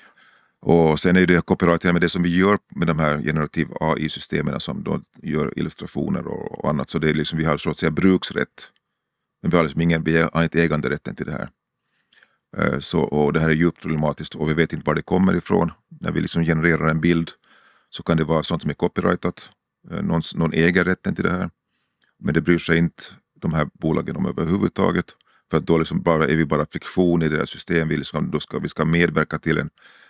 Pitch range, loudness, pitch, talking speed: 80-85 Hz, -21 LUFS, 80 Hz, 215 wpm